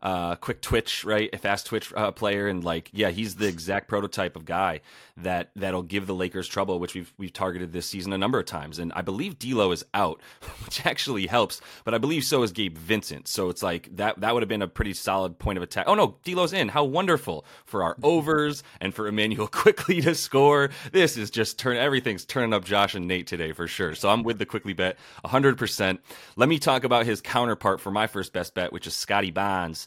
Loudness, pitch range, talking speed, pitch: -26 LUFS, 95-115 Hz, 240 wpm, 100 Hz